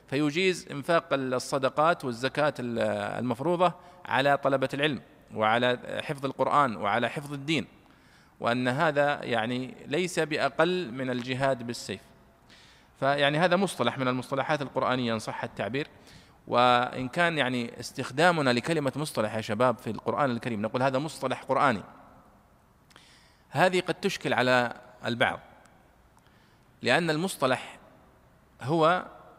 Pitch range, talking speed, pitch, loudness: 125-155 Hz, 110 wpm, 135 Hz, -27 LUFS